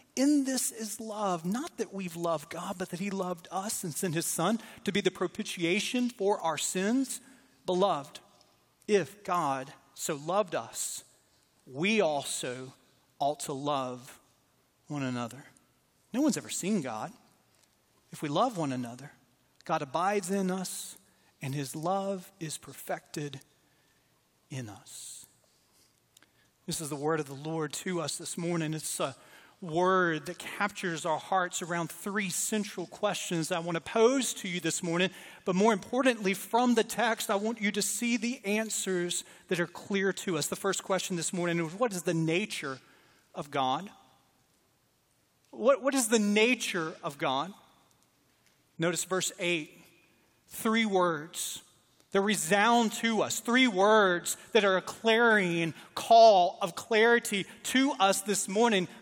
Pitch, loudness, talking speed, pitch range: 185 Hz, -30 LUFS, 150 wpm, 160-210 Hz